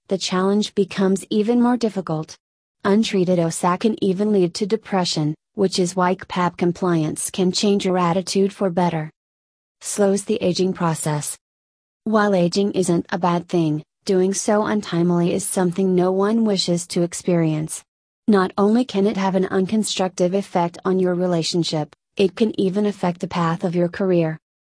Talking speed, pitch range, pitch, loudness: 155 wpm, 175-200 Hz, 185 Hz, -20 LUFS